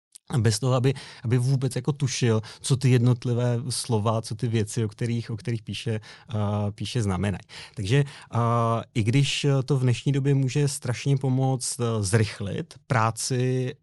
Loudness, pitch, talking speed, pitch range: -25 LUFS, 125 Hz, 155 wpm, 115-135 Hz